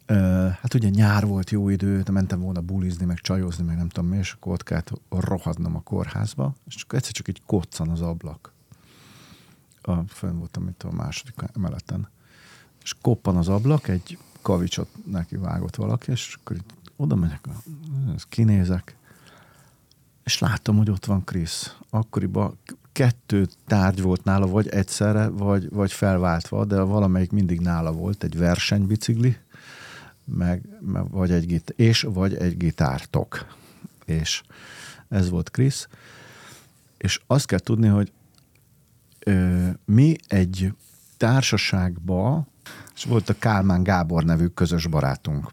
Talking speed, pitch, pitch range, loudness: 135 wpm, 100 Hz, 90-110 Hz, -23 LUFS